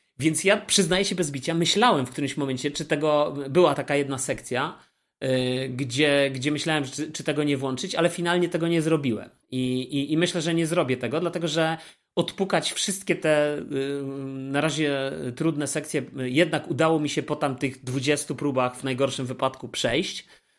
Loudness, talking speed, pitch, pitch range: -25 LUFS, 180 wpm, 150 Hz, 135-165 Hz